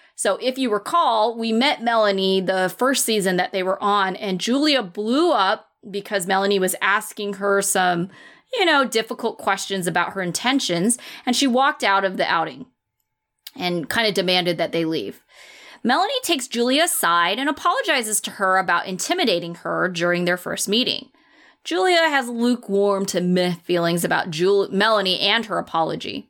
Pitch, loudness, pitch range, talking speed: 205 Hz, -20 LUFS, 185-250 Hz, 165 wpm